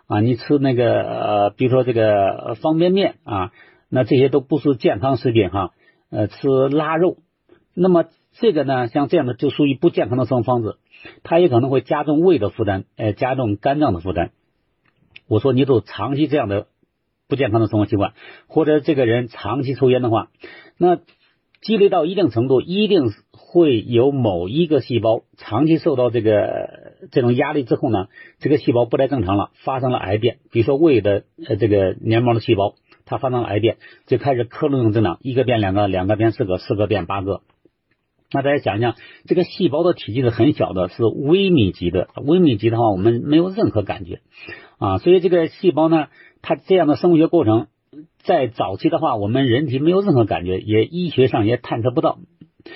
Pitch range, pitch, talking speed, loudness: 110-150 Hz, 125 Hz, 295 characters per minute, -18 LUFS